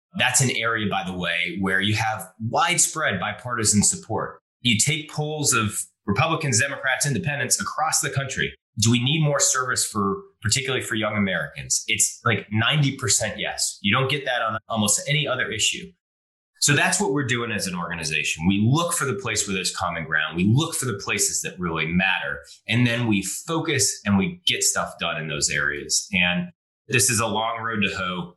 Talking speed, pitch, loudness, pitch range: 190 wpm, 115 Hz, -22 LUFS, 100-135 Hz